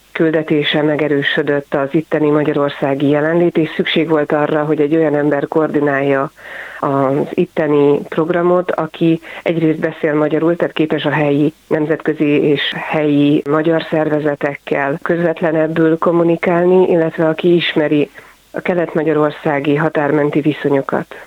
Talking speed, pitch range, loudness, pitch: 115 wpm, 145-165 Hz, -15 LUFS, 155 Hz